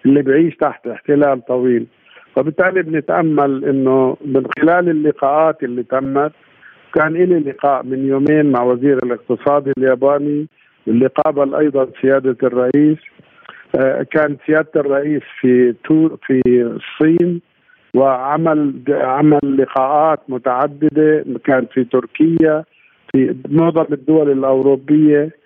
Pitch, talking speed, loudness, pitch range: 140 Hz, 105 wpm, -15 LUFS, 130-155 Hz